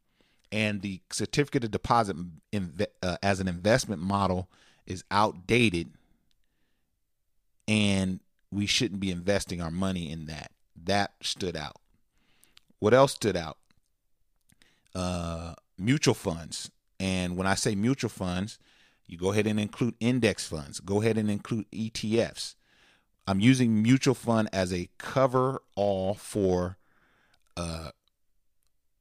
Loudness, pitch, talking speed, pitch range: -28 LUFS, 100 Hz, 125 wpm, 90-110 Hz